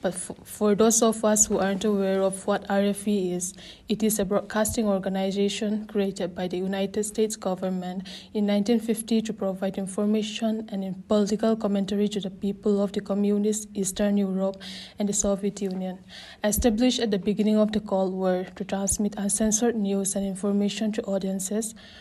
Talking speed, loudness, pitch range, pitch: 165 wpm, -25 LUFS, 195-215 Hz, 205 Hz